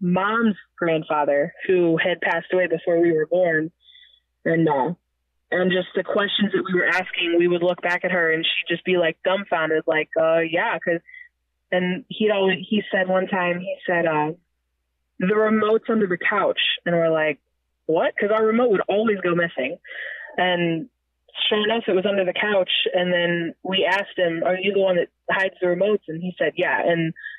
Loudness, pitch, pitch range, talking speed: -21 LUFS, 180 Hz, 165-195 Hz, 195 wpm